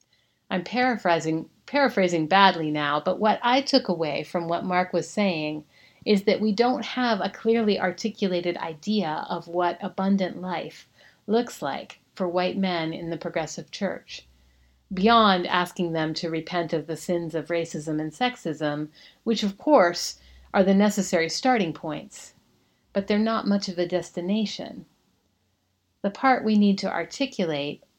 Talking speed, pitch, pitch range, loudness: 150 wpm, 180 Hz, 160-210 Hz, -25 LUFS